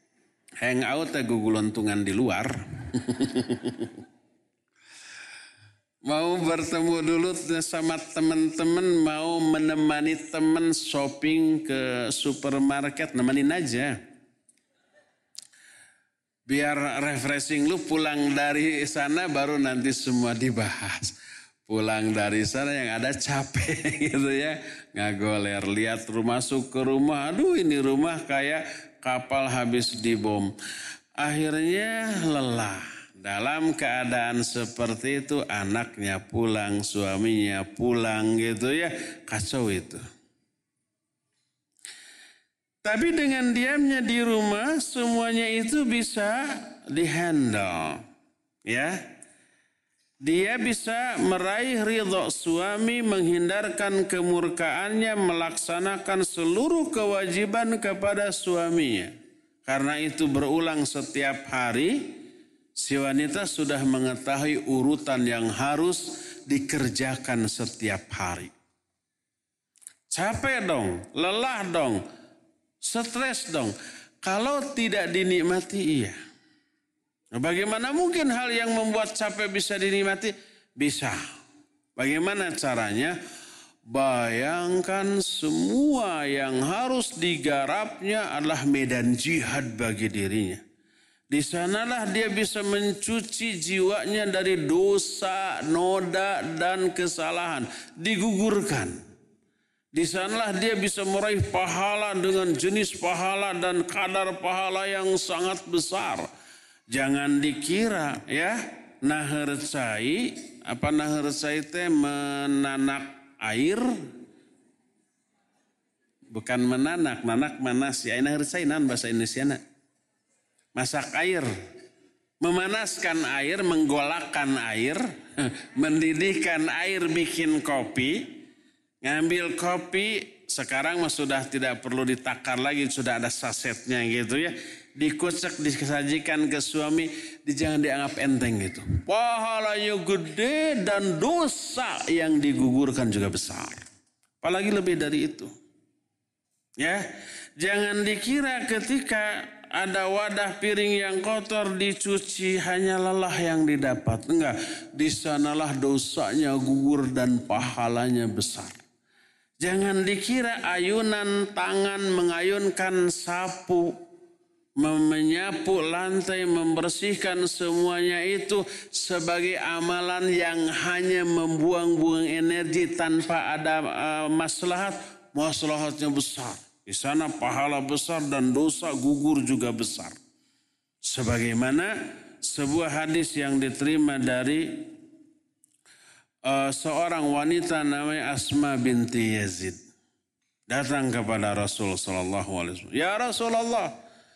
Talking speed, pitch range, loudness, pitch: 90 wpm, 140-215 Hz, -26 LUFS, 170 Hz